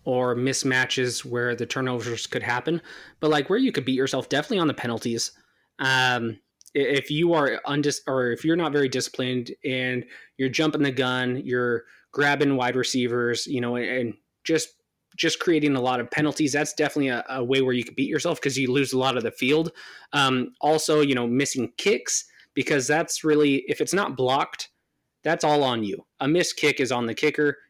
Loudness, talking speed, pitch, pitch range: -24 LUFS, 195 wpm, 130 Hz, 125-150 Hz